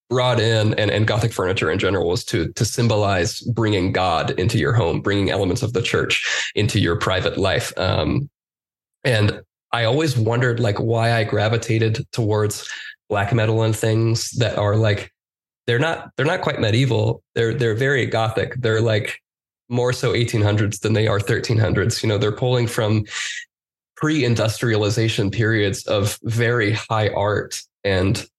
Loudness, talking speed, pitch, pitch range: -20 LUFS, 155 wpm, 110 Hz, 105-120 Hz